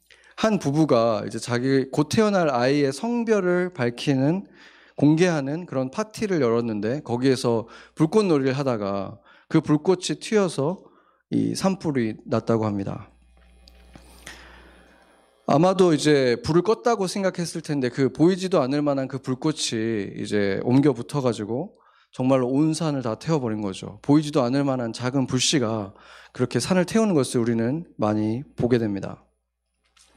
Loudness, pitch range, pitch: -23 LUFS, 115-160 Hz, 135 Hz